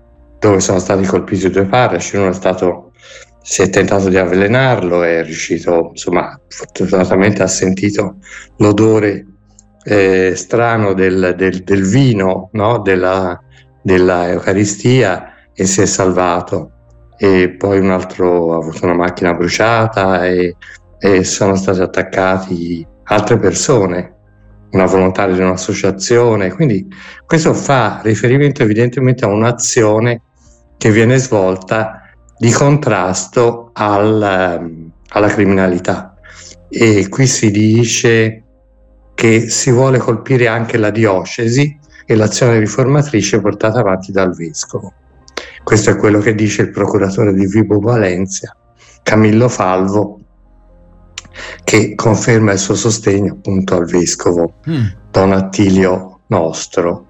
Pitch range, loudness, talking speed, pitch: 90-110 Hz, -12 LUFS, 115 wpm, 100 Hz